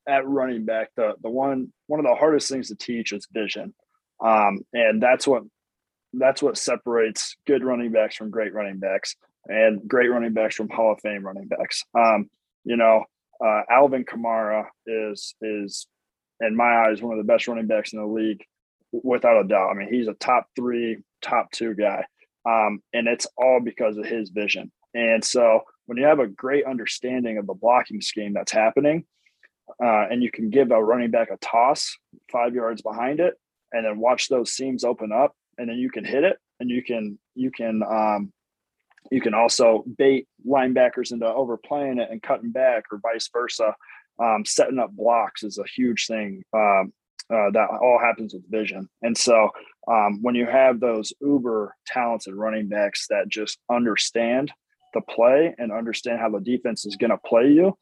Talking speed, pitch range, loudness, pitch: 190 wpm, 110-125 Hz, -22 LUFS, 115 Hz